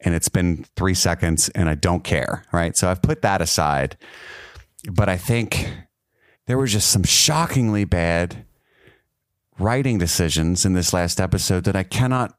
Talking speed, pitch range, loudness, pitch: 160 wpm, 85-115 Hz, -20 LUFS, 95 Hz